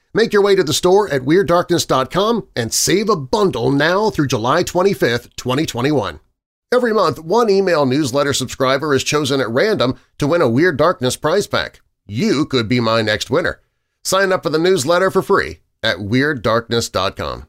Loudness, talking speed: -16 LUFS, 170 wpm